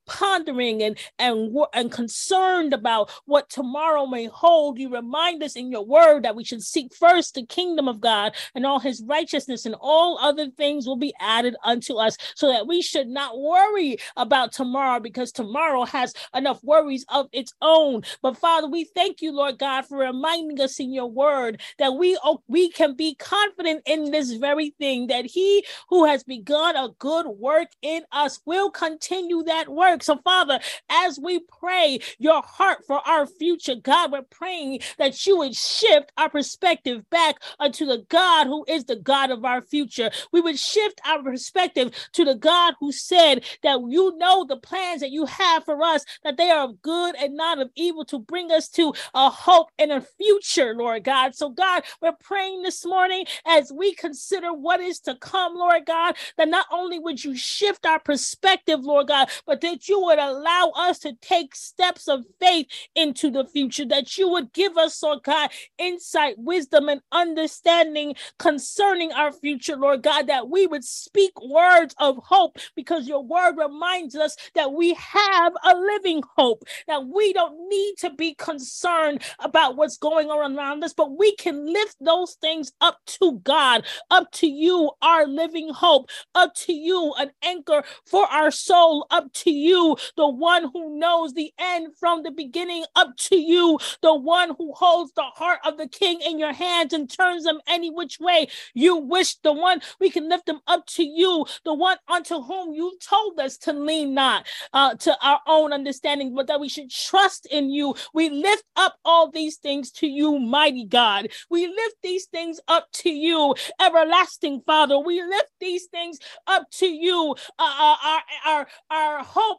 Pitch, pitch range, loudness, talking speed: 315 Hz, 280-350 Hz, -21 LUFS, 185 wpm